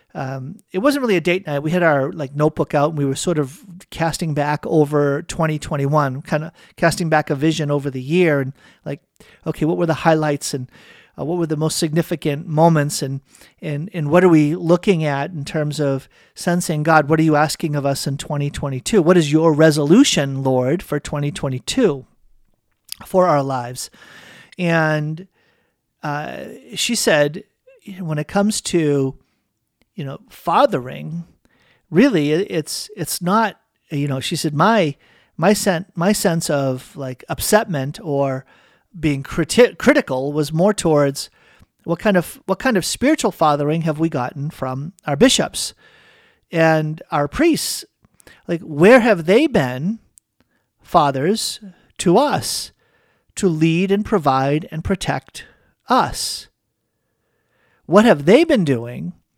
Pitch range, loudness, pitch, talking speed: 145-185 Hz, -18 LUFS, 160 Hz, 155 wpm